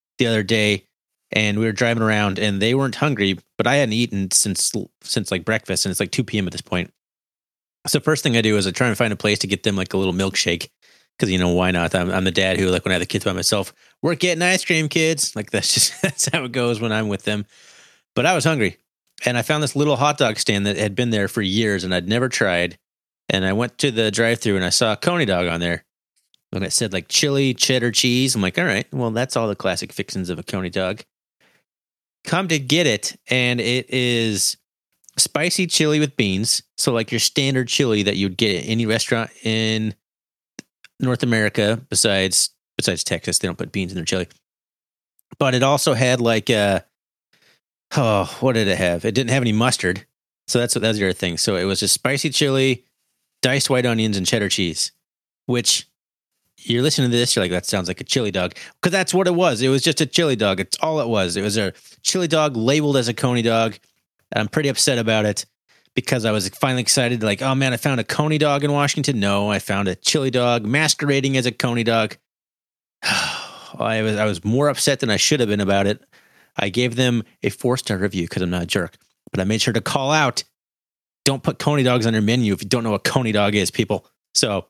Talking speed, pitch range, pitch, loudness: 230 wpm, 100-130 Hz, 115 Hz, -19 LUFS